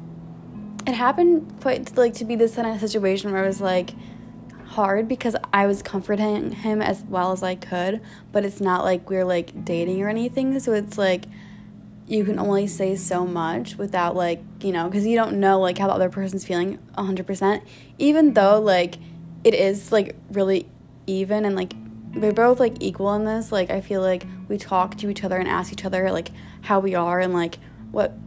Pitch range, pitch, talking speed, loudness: 185-210 Hz, 195 Hz, 205 wpm, -22 LUFS